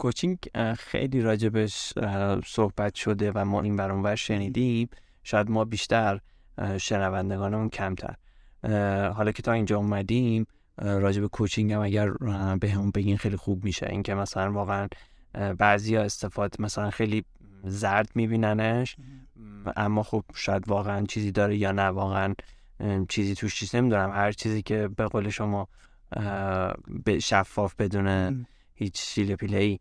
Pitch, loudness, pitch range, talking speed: 105 Hz, -27 LUFS, 100-110 Hz, 130 wpm